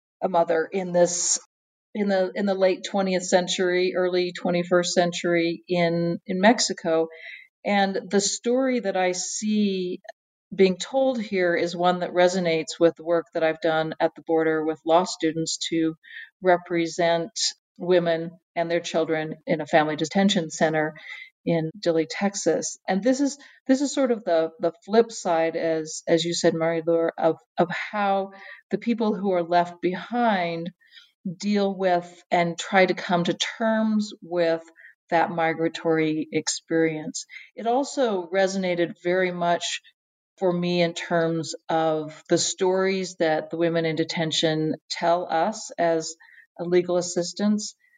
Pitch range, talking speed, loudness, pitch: 165-195 Hz, 145 wpm, -24 LUFS, 175 Hz